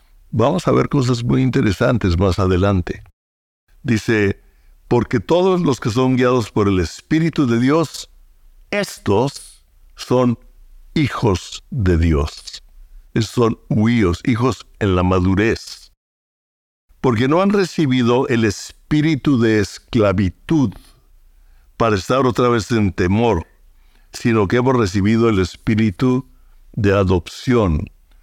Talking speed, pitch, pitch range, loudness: 115 wpm, 110 Hz, 95-125 Hz, -17 LUFS